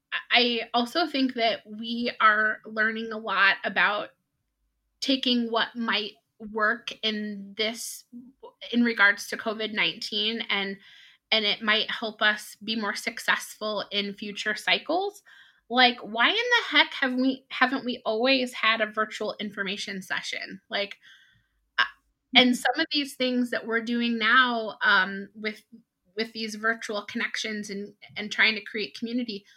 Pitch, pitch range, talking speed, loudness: 225 Hz, 210-245 Hz, 140 wpm, -25 LUFS